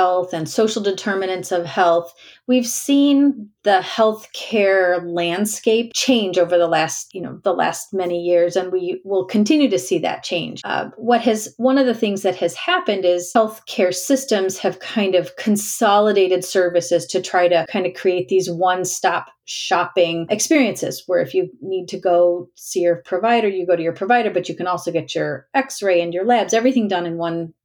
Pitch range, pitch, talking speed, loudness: 175-220 Hz, 185 Hz, 190 wpm, -19 LUFS